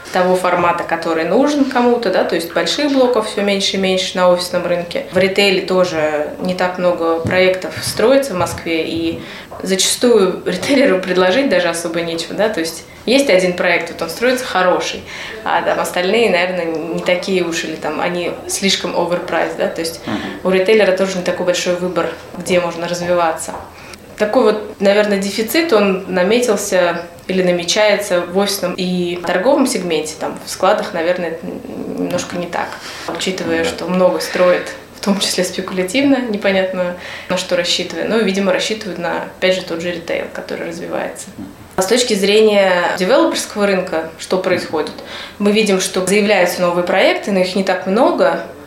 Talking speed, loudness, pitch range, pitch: 165 wpm, -16 LUFS, 175-205 Hz, 185 Hz